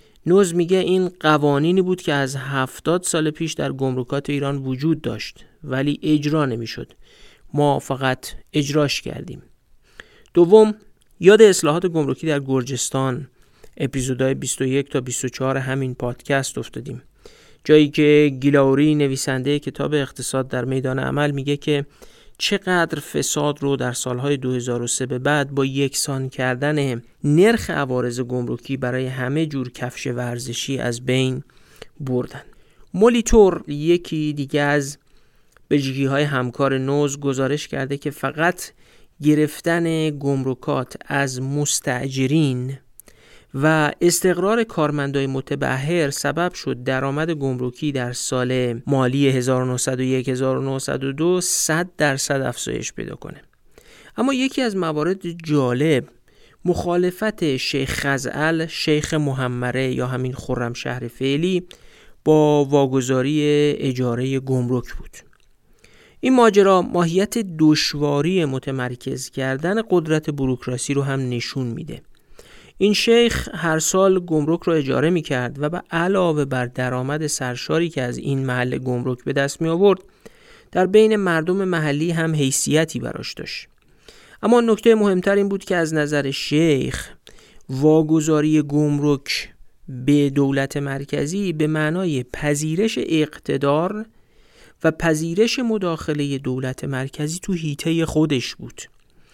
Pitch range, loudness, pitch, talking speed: 130-165 Hz, -20 LUFS, 145 Hz, 115 wpm